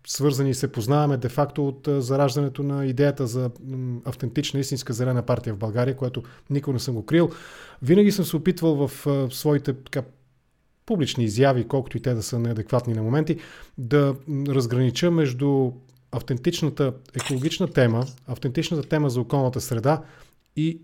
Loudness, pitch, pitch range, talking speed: -24 LUFS, 135 Hz, 125-145 Hz, 145 wpm